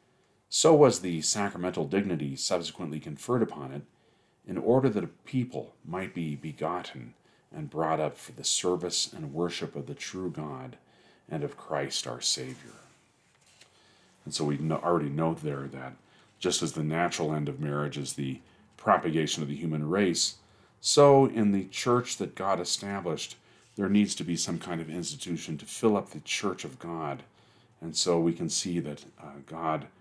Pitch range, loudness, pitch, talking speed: 75-95 Hz, -29 LUFS, 85 Hz, 170 wpm